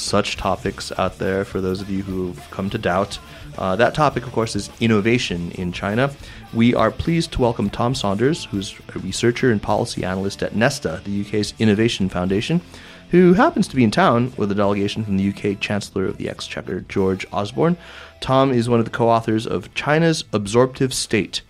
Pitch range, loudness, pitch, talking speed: 100-125 Hz, -20 LUFS, 110 Hz, 195 wpm